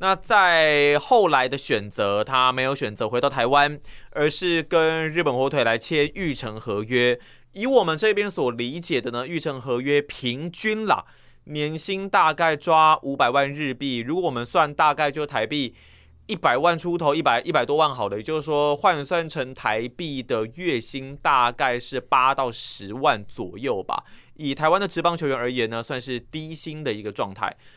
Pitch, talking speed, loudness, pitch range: 145 Hz, 260 characters per minute, -22 LUFS, 125-160 Hz